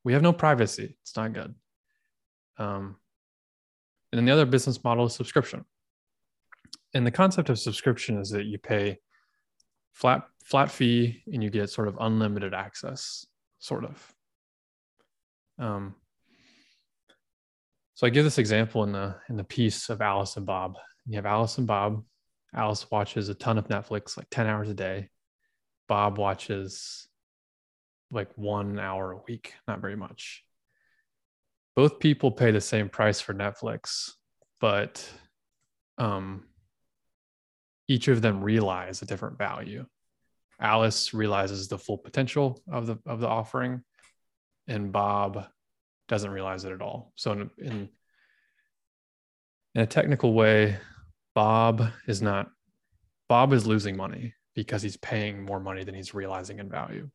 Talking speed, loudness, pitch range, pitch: 145 wpm, -27 LUFS, 100-120 Hz, 105 Hz